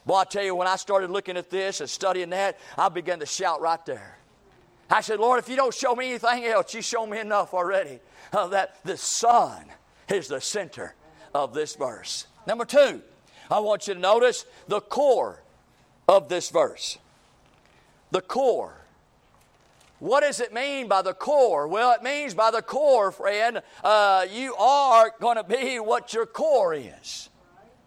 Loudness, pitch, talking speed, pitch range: -24 LUFS, 220 Hz, 175 wpm, 195-255 Hz